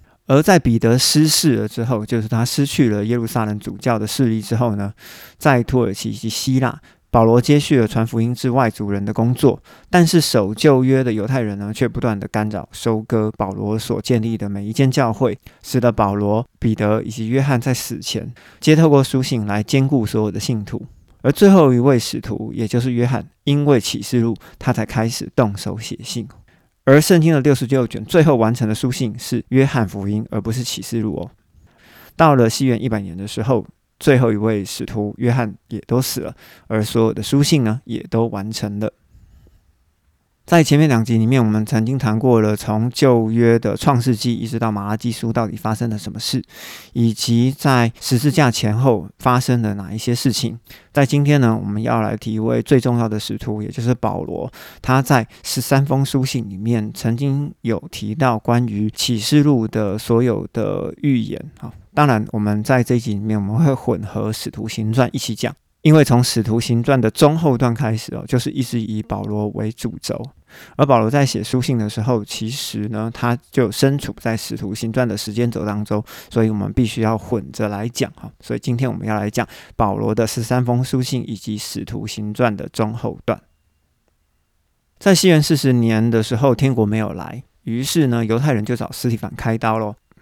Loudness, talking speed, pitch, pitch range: -18 LUFS, 285 characters per minute, 115 Hz, 110-130 Hz